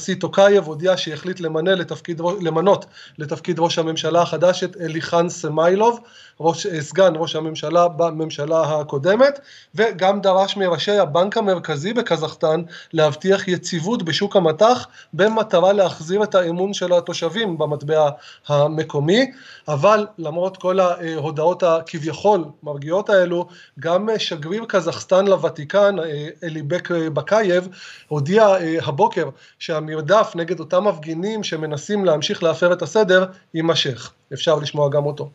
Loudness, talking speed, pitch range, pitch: -19 LUFS, 110 wpm, 160-190 Hz, 175 Hz